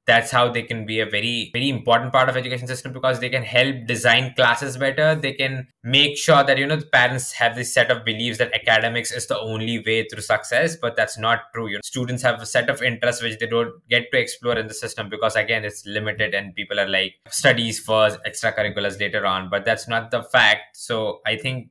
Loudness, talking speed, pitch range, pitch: -20 LUFS, 230 wpm, 110-130 Hz, 115 Hz